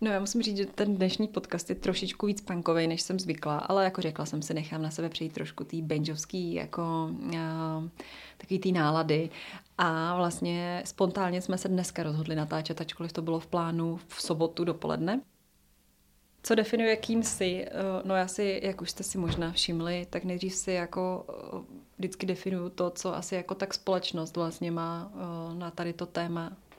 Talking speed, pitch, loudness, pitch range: 175 wpm, 175 Hz, -31 LUFS, 165-190 Hz